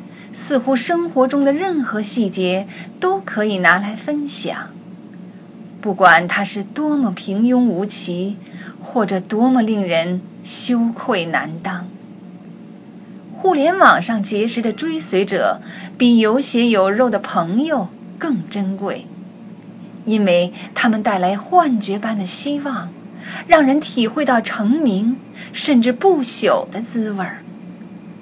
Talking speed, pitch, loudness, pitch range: 180 characters per minute, 210 Hz, -17 LUFS, 195-250 Hz